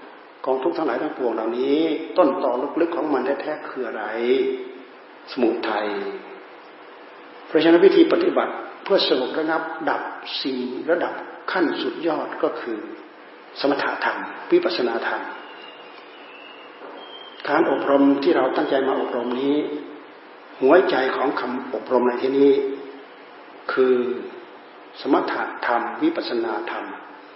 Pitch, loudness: 340 Hz, -22 LUFS